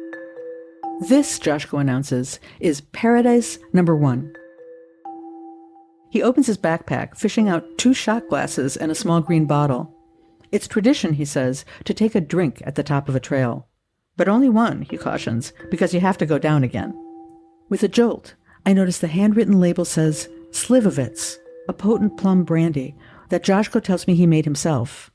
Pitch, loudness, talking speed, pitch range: 165 Hz, -20 LUFS, 160 wpm, 150-195 Hz